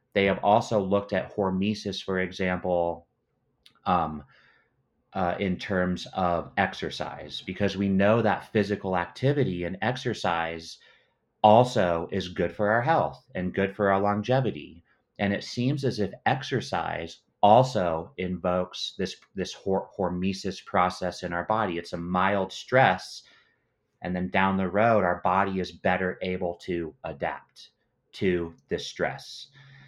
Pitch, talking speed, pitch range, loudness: 95 Hz, 135 wpm, 90-105 Hz, -27 LUFS